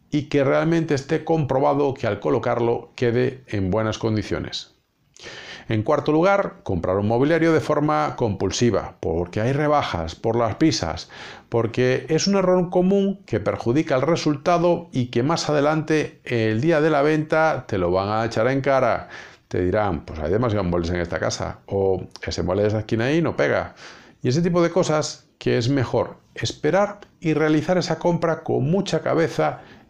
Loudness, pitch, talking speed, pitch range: -22 LUFS, 140 Hz, 175 wpm, 110-160 Hz